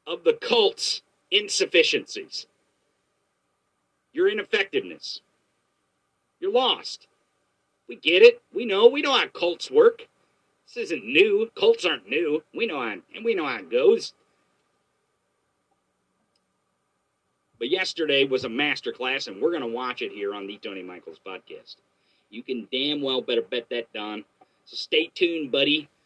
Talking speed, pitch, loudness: 140 wpm, 395 Hz, -23 LUFS